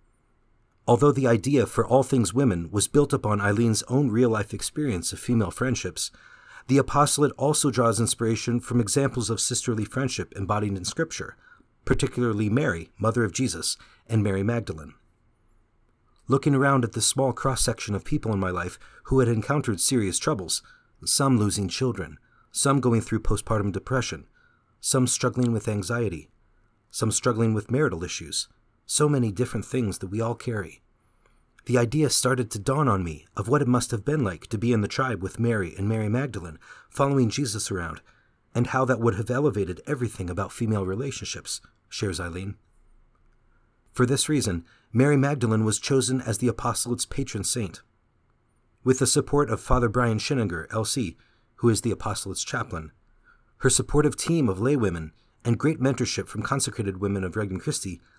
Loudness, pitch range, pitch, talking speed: -25 LUFS, 105-130 Hz, 115 Hz, 165 wpm